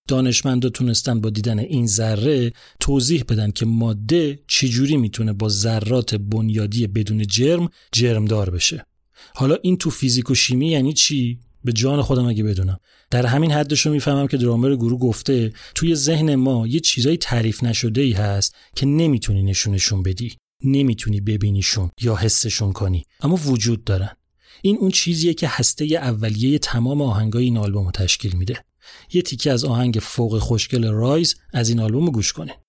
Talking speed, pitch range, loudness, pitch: 160 wpm, 110-140 Hz, -19 LUFS, 120 Hz